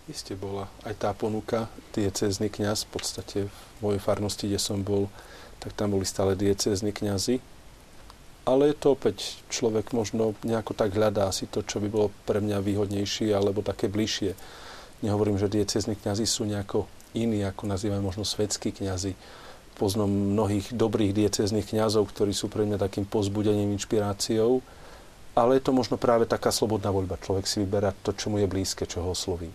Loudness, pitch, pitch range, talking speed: -27 LUFS, 105 Hz, 100-110 Hz, 170 wpm